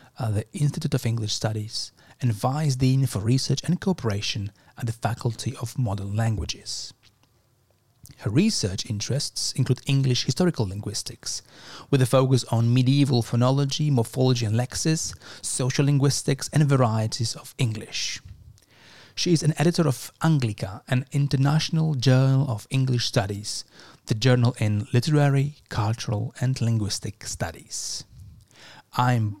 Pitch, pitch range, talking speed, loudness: 125 Hz, 110-140 Hz, 125 wpm, -24 LUFS